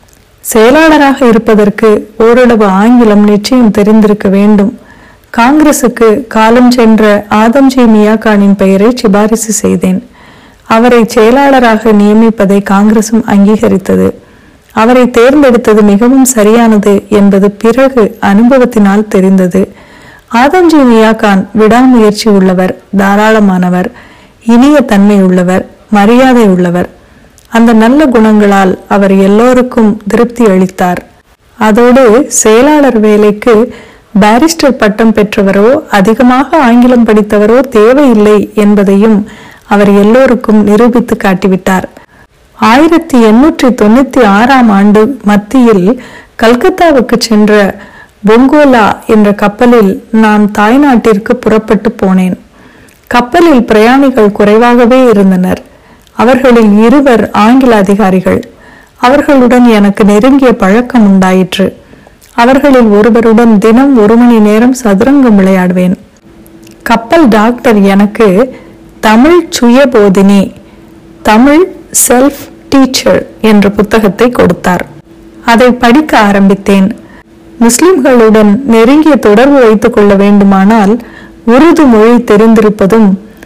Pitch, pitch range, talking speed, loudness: 225 Hz, 205-245 Hz, 85 wpm, -5 LUFS